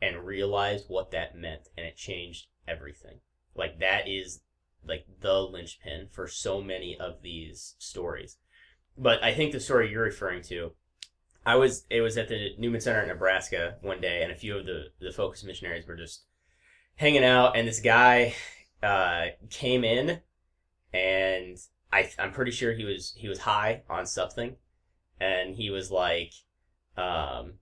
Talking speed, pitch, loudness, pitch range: 165 wpm, 95 Hz, -28 LUFS, 85-115 Hz